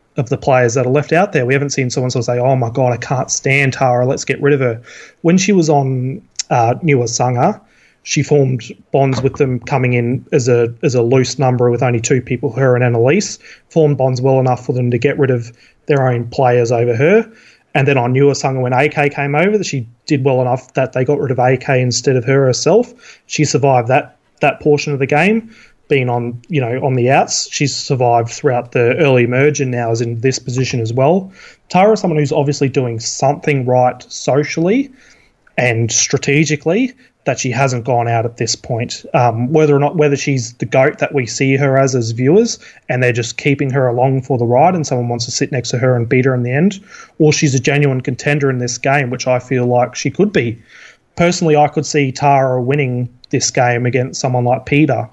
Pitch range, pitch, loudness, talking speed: 125-145 Hz, 135 Hz, -14 LUFS, 225 wpm